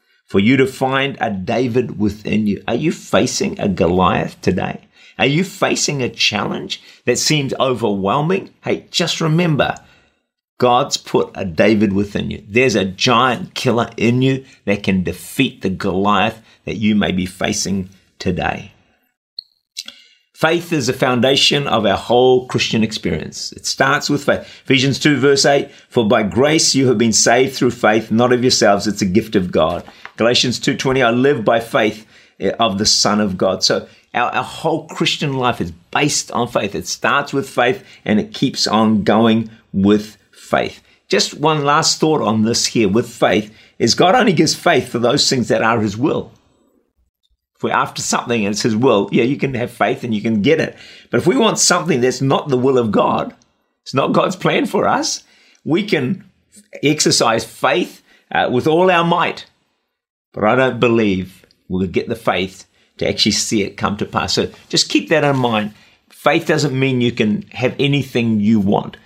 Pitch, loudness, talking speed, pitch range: 125 Hz, -16 LUFS, 180 wpm, 105-140 Hz